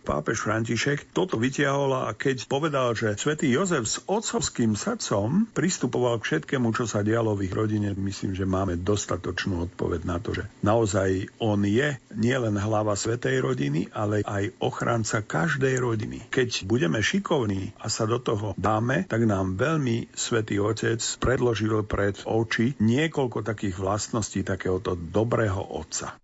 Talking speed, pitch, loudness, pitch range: 145 wpm, 110 Hz, -26 LUFS, 100-125 Hz